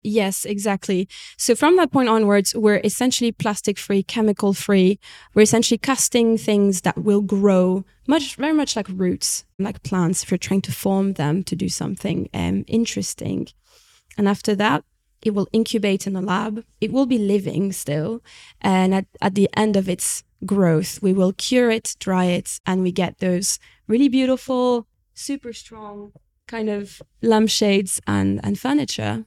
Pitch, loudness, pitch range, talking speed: 205 Hz, -20 LUFS, 185-225 Hz, 165 wpm